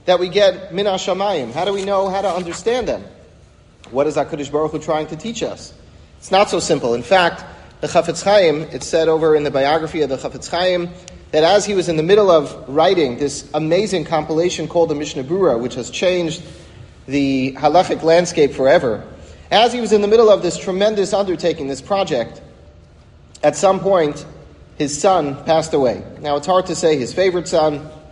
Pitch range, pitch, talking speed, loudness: 145-190 Hz, 160 Hz, 195 wpm, -17 LUFS